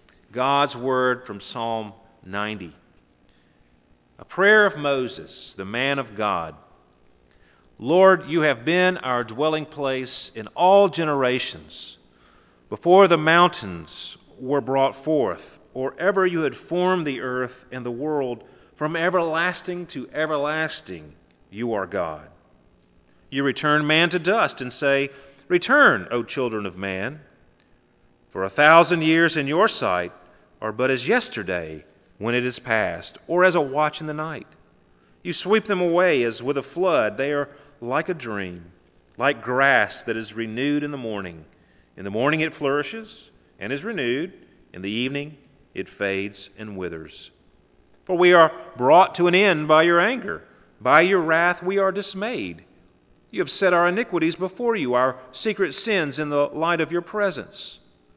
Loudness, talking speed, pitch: -21 LUFS, 155 wpm, 135 Hz